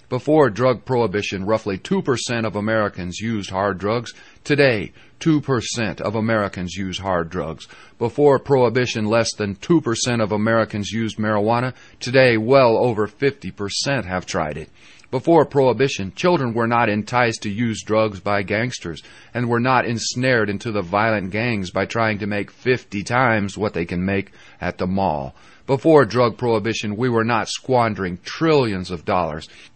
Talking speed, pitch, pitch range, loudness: 150 wpm, 110 Hz, 100-125 Hz, -20 LUFS